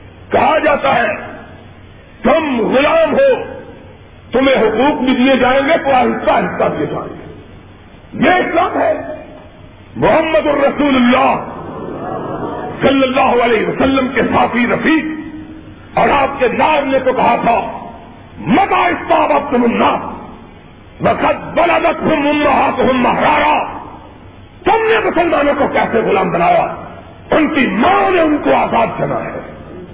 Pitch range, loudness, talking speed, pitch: 260-315 Hz, -13 LUFS, 125 wpm, 290 Hz